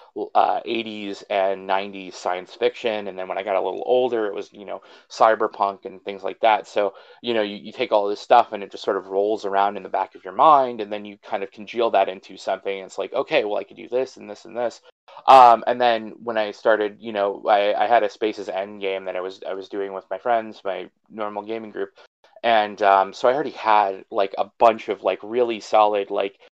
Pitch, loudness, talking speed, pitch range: 105 Hz, -22 LUFS, 245 wpm, 100-115 Hz